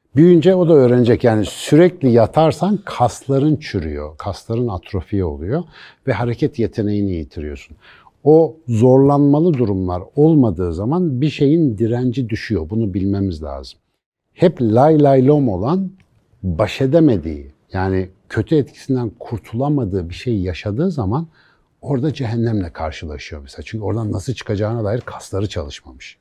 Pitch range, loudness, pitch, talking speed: 95-145 Hz, -17 LUFS, 115 Hz, 125 wpm